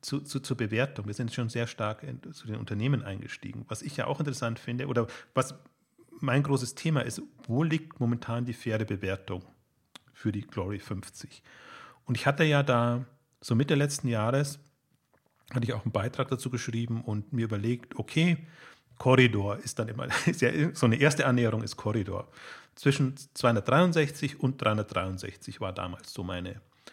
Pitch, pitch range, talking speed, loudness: 125 Hz, 110-140 Hz, 165 wpm, -30 LUFS